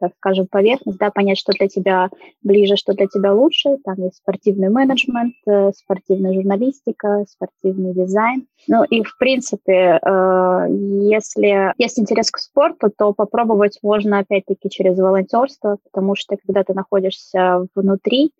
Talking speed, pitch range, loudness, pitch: 135 wpm, 190-220 Hz, -17 LUFS, 200 Hz